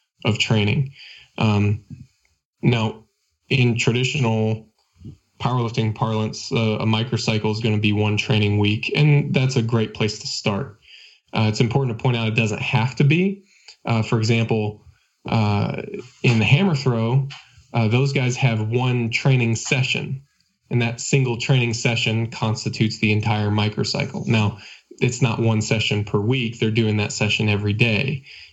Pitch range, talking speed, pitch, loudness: 110-130 Hz, 155 wpm, 115 Hz, -21 LUFS